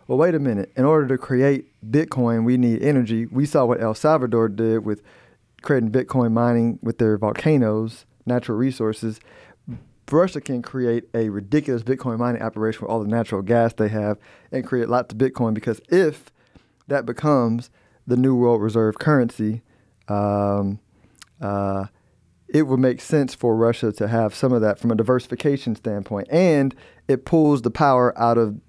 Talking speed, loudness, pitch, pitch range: 165 wpm, -21 LUFS, 120 Hz, 110-130 Hz